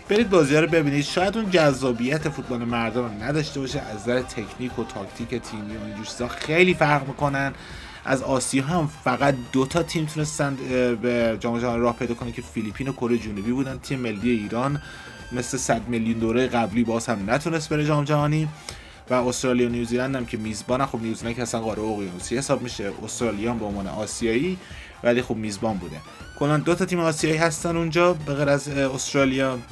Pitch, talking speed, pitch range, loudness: 125 Hz, 185 wpm, 115-145 Hz, -24 LUFS